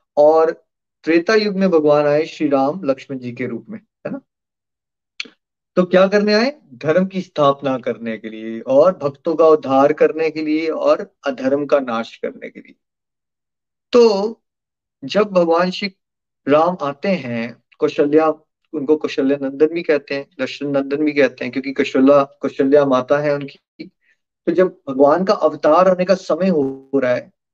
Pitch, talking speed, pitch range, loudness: 150 Hz, 165 wpm, 140-180 Hz, -17 LUFS